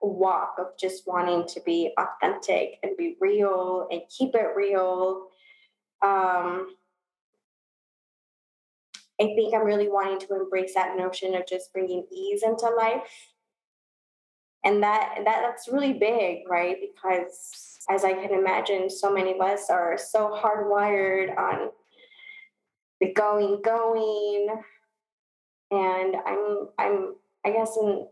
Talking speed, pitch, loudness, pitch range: 125 wpm, 200 Hz, -26 LUFS, 185-225 Hz